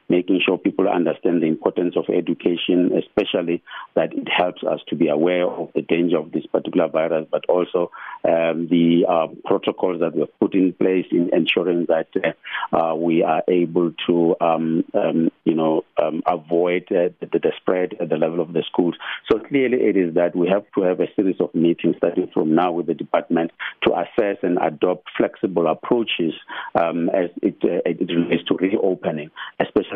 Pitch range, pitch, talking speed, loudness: 85-90 Hz, 85 Hz, 190 wpm, -20 LUFS